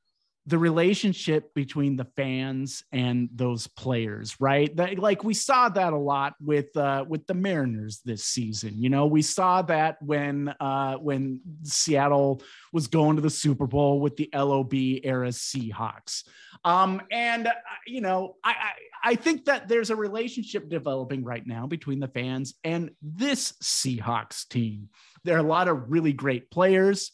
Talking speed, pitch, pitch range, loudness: 165 wpm, 145 Hz, 130-180 Hz, -26 LUFS